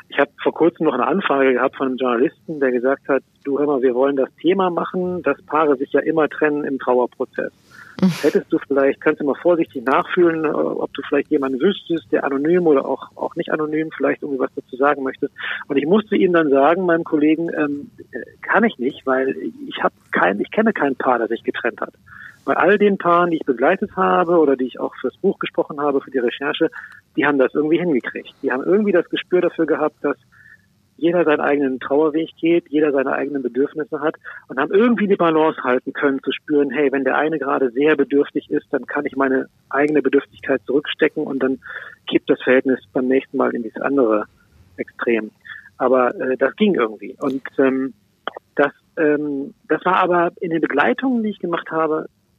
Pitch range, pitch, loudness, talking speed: 135-170 Hz, 150 Hz, -19 LUFS, 205 wpm